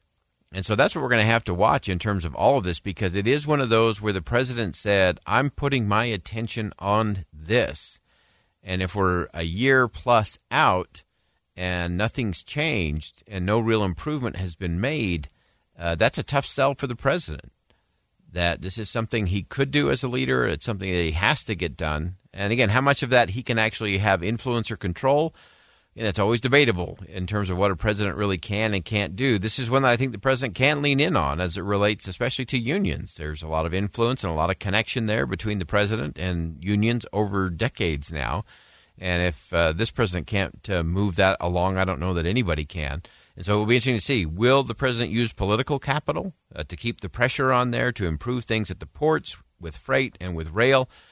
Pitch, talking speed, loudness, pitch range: 105 Hz, 220 wpm, -24 LUFS, 90-120 Hz